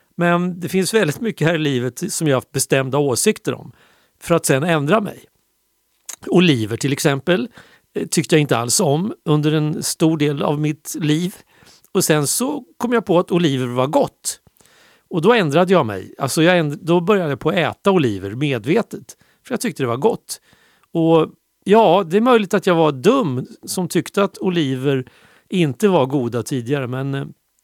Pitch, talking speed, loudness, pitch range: 165 Hz, 185 wpm, -18 LUFS, 140-185 Hz